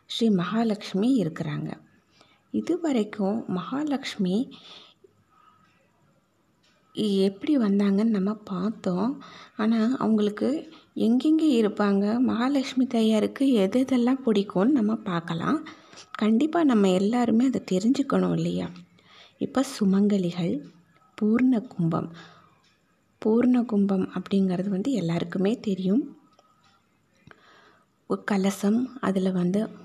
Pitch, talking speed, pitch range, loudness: 215 Hz, 80 wpm, 190-250 Hz, -25 LUFS